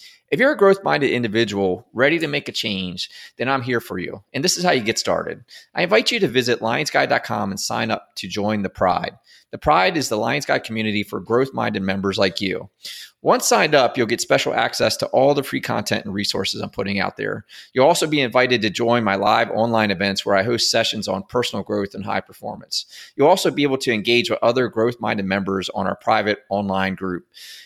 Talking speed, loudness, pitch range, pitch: 215 wpm, -20 LUFS, 100-125 Hz, 110 Hz